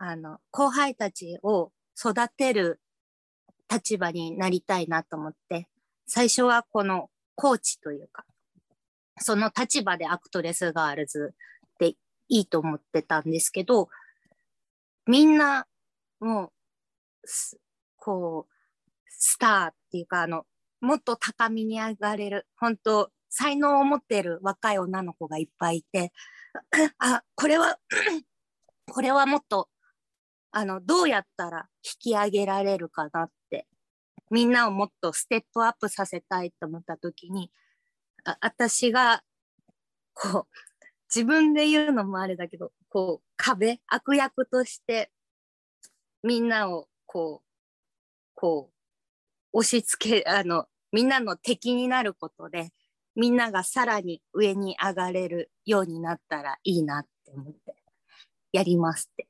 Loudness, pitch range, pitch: -26 LUFS, 170-245 Hz, 205 Hz